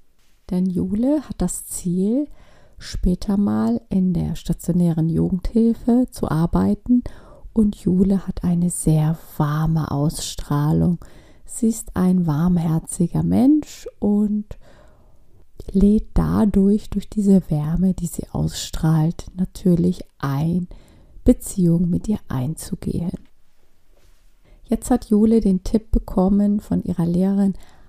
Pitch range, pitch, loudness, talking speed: 160-210 Hz, 185 Hz, -20 LUFS, 105 wpm